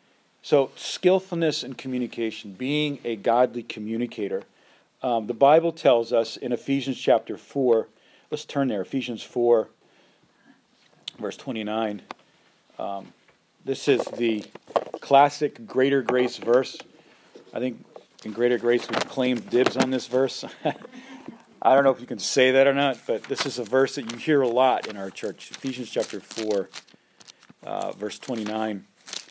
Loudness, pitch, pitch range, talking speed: -24 LUFS, 125 Hz, 115-135 Hz, 145 wpm